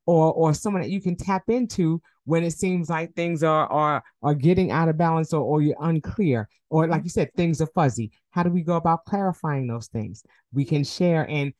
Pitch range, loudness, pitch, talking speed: 150-175 Hz, -23 LUFS, 165 Hz, 220 wpm